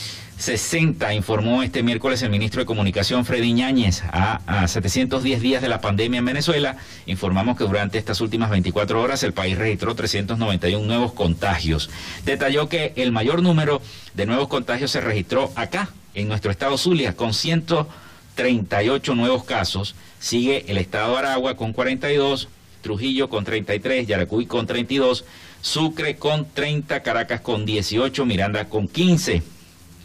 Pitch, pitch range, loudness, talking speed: 110 Hz, 95-130 Hz, -21 LUFS, 145 wpm